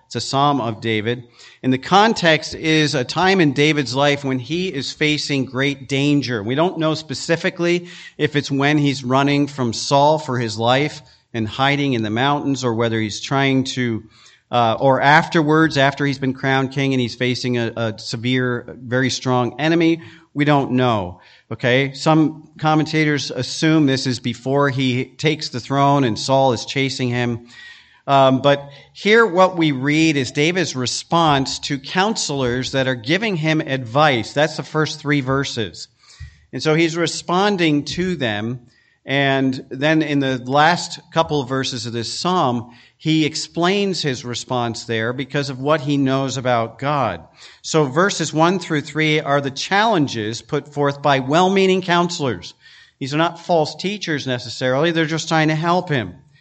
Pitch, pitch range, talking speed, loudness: 140 Hz, 125-155 Hz, 165 wpm, -18 LUFS